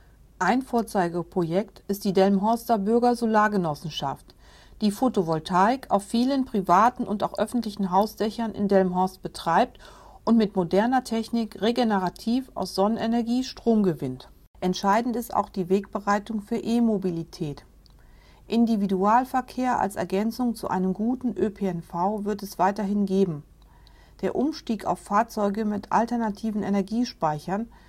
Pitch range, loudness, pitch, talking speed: 190-230 Hz, -25 LUFS, 205 Hz, 110 wpm